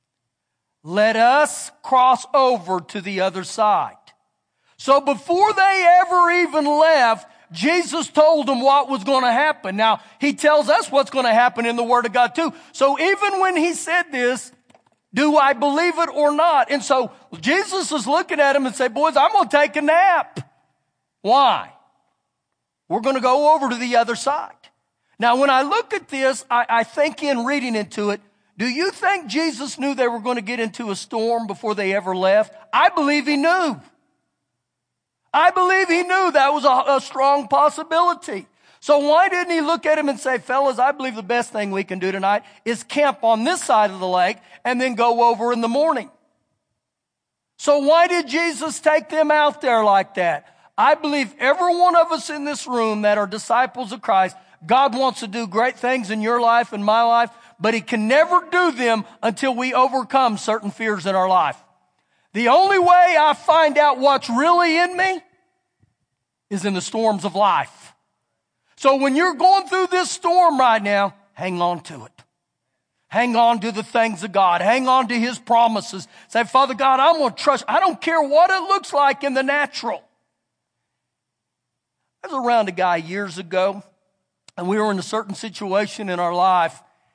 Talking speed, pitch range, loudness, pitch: 190 wpm, 220-310 Hz, -18 LUFS, 260 Hz